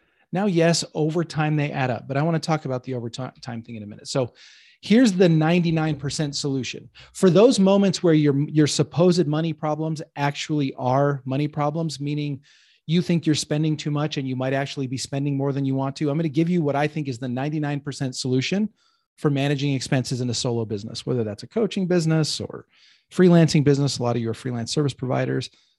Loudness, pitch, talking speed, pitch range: -22 LUFS, 145 Hz, 210 wpm, 130-160 Hz